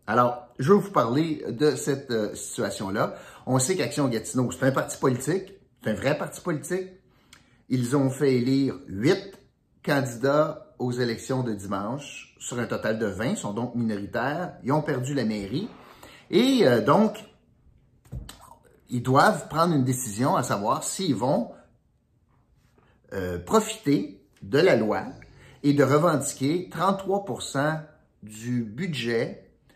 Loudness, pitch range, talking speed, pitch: -25 LUFS, 120-150 Hz, 140 wpm, 135 Hz